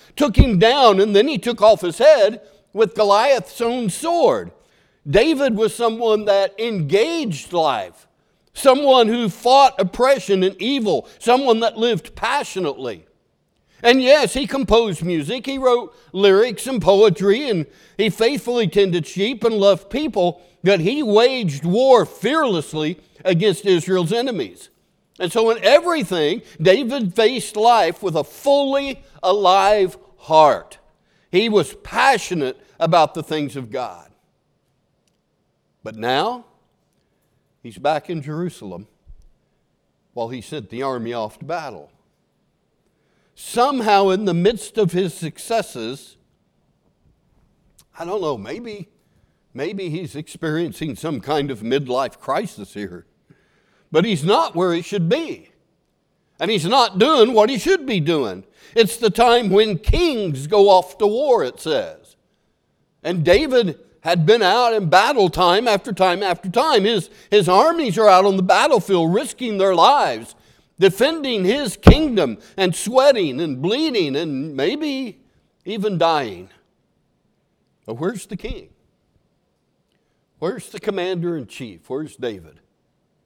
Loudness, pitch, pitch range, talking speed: -18 LUFS, 200 Hz, 175-235 Hz, 130 wpm